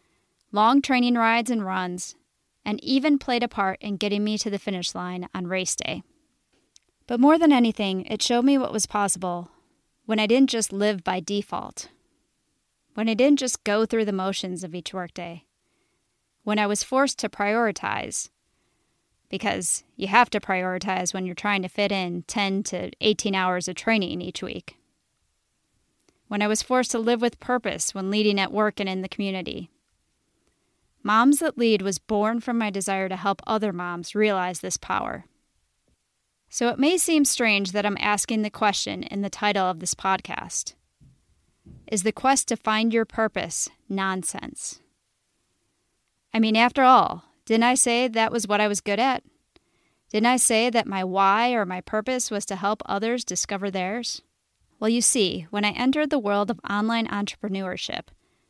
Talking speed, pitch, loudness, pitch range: 170 wpm, 210 Hz, -24 LUFS, 195-235 Hz